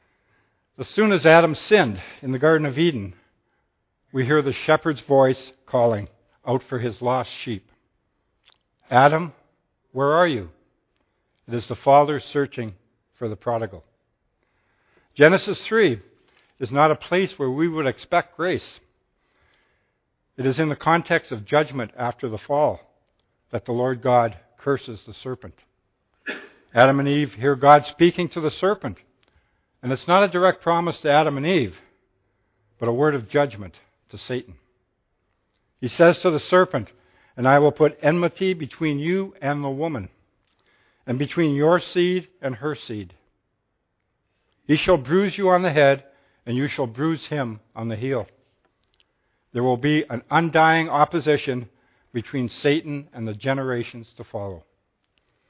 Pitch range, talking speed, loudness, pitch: 115-155 Hz, 150 wpm, -21 LUFS, 135 Hz